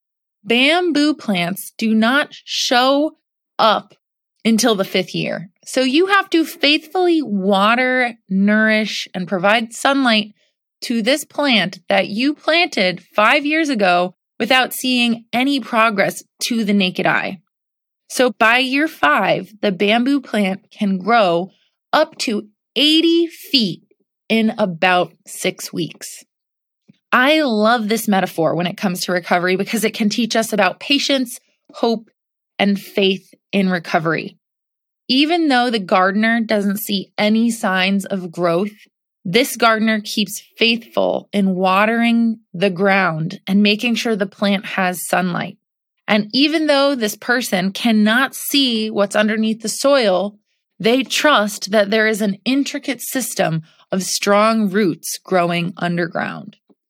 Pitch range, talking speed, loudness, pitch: 195-255 Hz, 130 wpm, -17 LUFS, 215 Hz